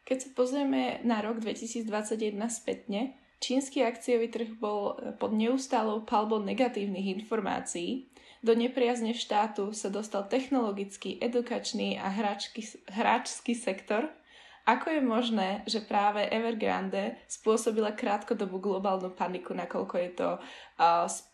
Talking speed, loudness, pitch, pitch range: 115 wpm, -31 LUFS, 225 Hz, 205-245 Hz